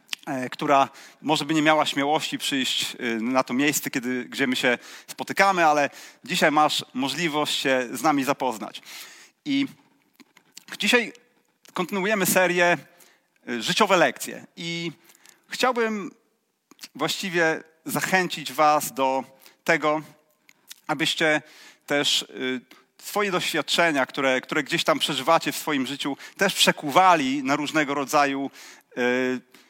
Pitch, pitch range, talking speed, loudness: 150 Hz, 135-170 Hz, 105 wpm, -23 LUFS